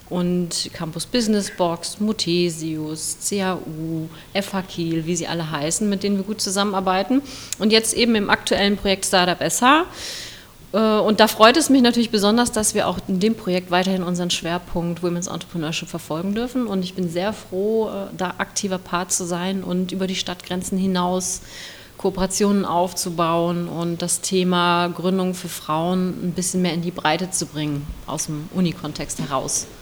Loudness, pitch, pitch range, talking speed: -21 LUFS, 180 Hz, 170-200 Hz, 160 wpm